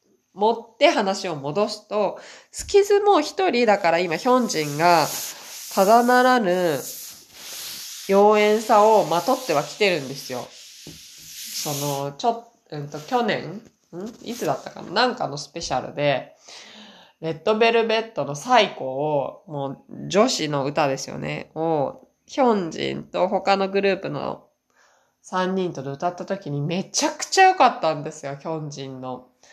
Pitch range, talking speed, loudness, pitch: 145-225 Hz, 280 characters per minute, -22 LUFS, 180 Hz